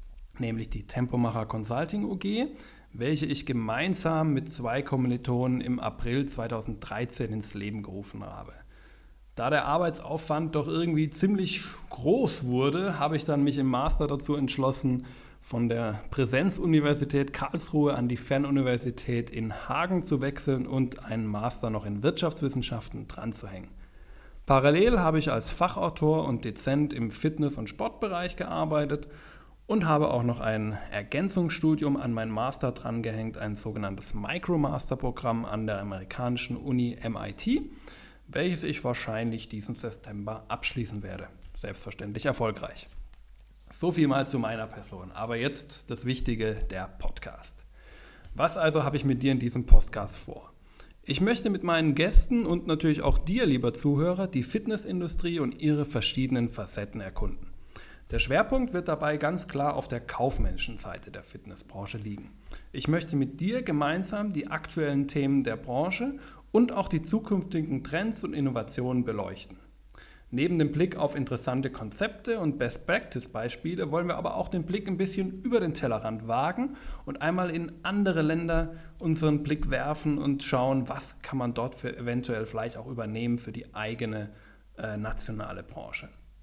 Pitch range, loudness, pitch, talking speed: 115-160 Hz, -29 LUFS, 135 Hz, 145 wpm